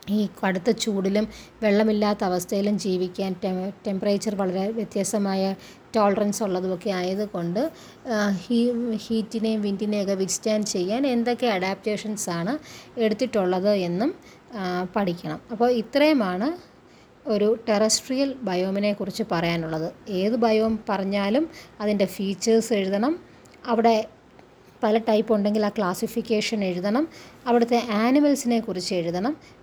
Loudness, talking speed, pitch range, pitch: -24 LUFS, 95 wpm, 195-230 Hz, 210 Hz